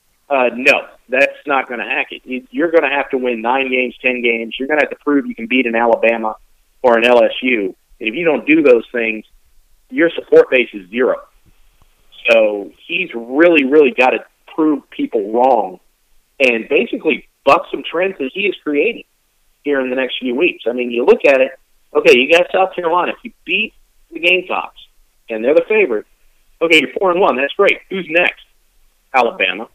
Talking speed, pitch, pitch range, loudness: 200 wpm, 145 Hz, 120-195 Hz, -15 LUFS